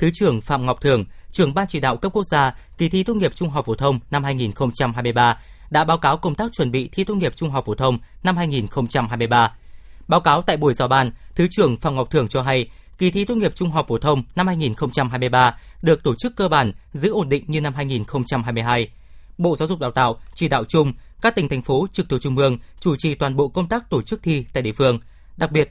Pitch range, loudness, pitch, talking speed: 125-175 Hz, -20 LUFS, 145 Hz, 240 wpm